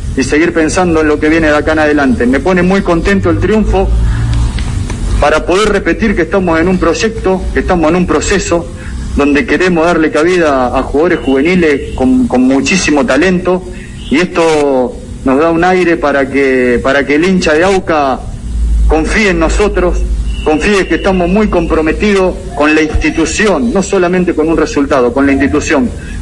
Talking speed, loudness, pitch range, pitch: 170 wpm, -10 LUFS, 140-180 Hz, 160 Hz